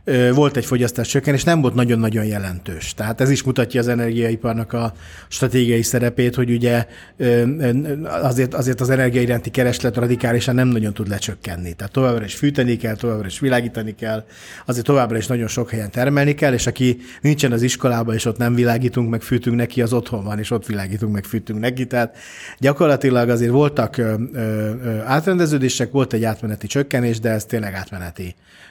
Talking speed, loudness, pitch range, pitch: 170 wpm, -19 LUFS, 110-130 Hz, 120 Hz